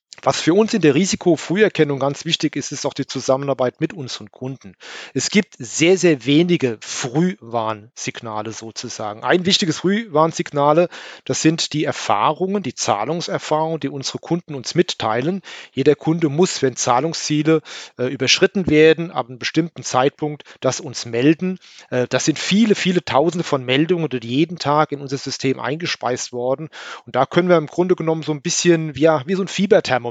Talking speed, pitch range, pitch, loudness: 165 wpm, 130-170 Hz, 150 Hz, -19 LUFS